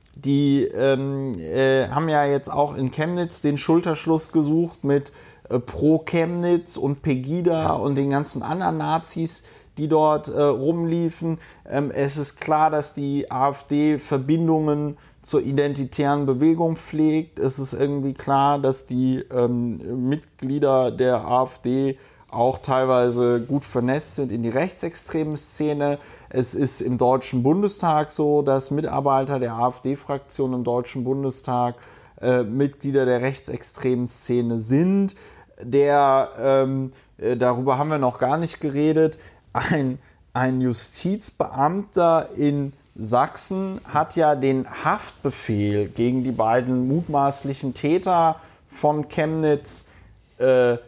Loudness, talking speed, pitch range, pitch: -22 LUFS, 120 wpm, 130-155 Hz, 140 Hz